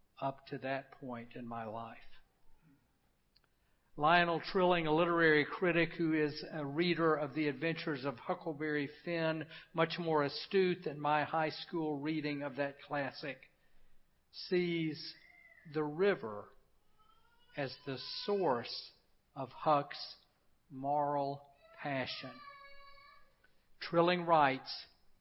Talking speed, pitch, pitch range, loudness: 105 wpm, 155 Hz, 145-175 Hz, -35 LUFS